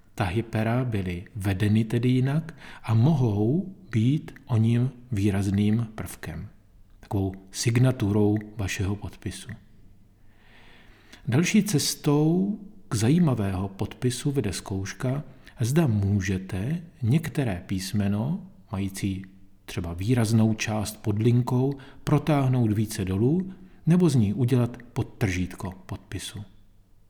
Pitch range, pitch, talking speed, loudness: 100-130 Hz, 110 Hz, 95 wpm, -26 LUFS